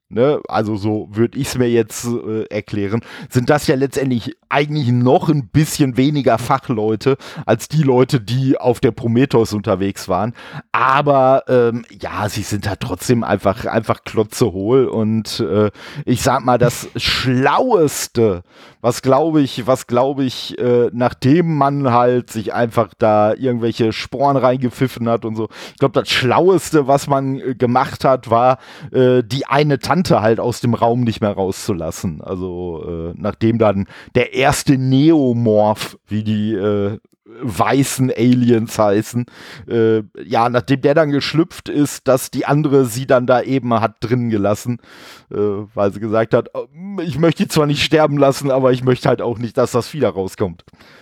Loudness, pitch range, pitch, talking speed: -16 LUFS, 110-135 Hz, 120 Hz, 160 wpm